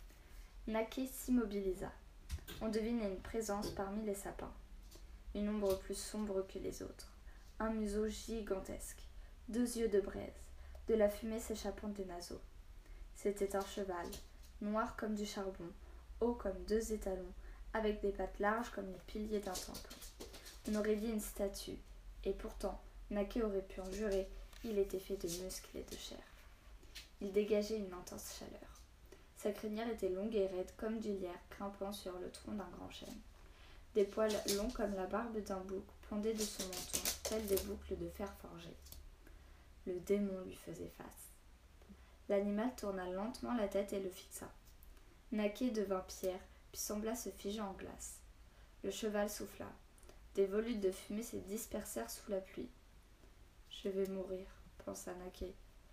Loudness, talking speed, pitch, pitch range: -42 LUFS, 160 wpm, 200 Hz, 185-215 Hz